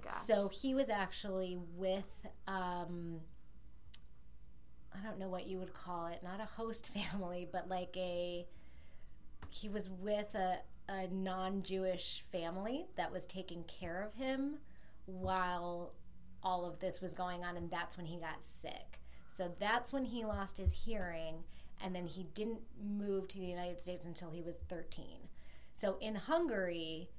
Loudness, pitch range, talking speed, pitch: -42 LUFS, 170-195 Hz, 155 wpm, 185 Hz